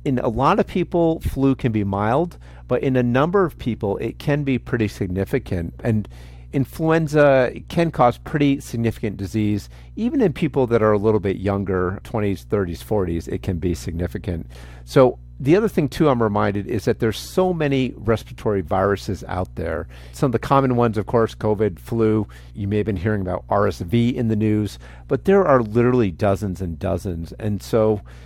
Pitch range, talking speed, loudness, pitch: 95-130 Hz, 185 wpm, -21 LUFS, 110 Hz